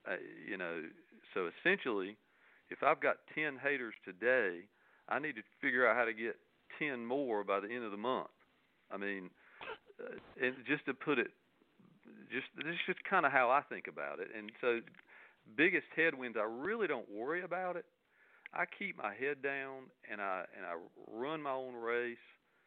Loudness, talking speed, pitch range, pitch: -37 LUFS, 185 wpm, 120-160 Hz, 135 Hz